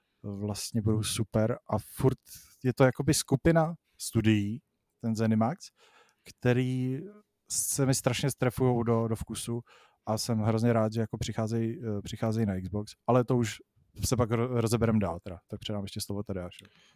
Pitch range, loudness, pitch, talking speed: 105-125 Hz, -30 LUFS, 115 Hz, 150 wpm